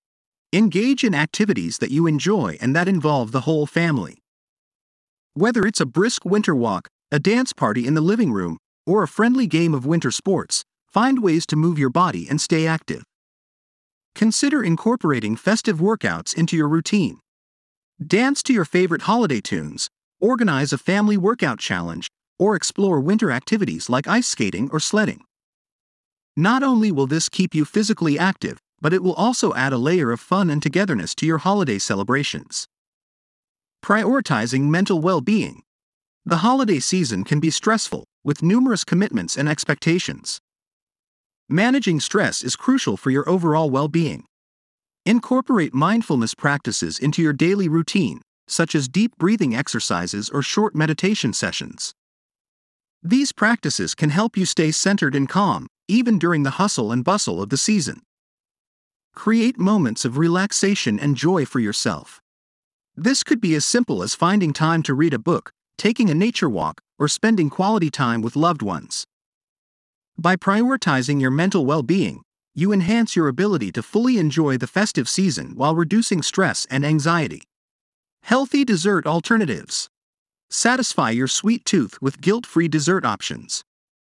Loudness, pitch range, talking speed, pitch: -20 LUFS, 150-215 Hz, 150 wpm, 175 Hz